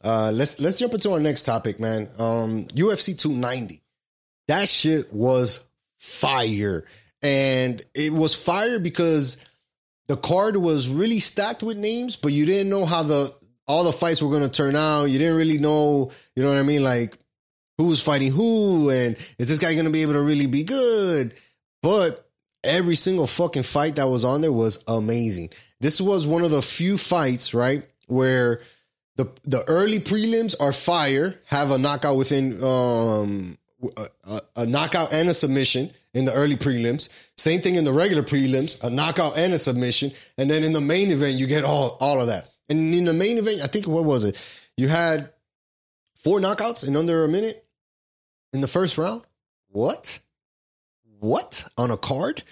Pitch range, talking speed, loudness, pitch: 125-170 Hz, 185 wpm, -22 LUFS, 145 Hz